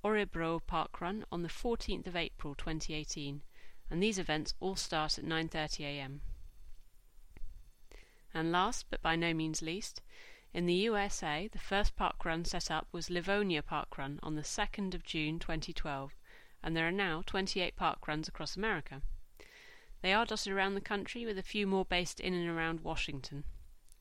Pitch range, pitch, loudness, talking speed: 155-195 Hz, 170 Hz, -36 LUFS, 165 wpm